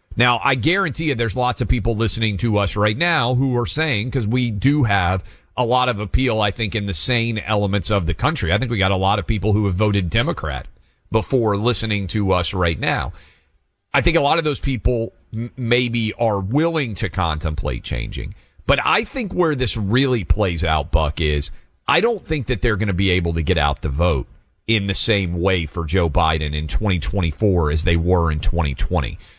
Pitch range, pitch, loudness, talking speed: 90-120 Hz, 105 Hz, -20 LUFS, 210 wpm